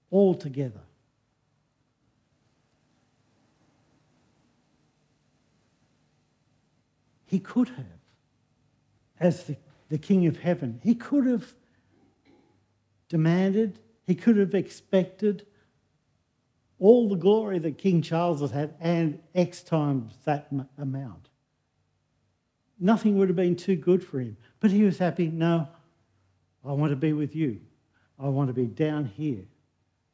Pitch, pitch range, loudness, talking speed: 155 Hz, 135-185 Hz, -26 LUFS, 115 wpm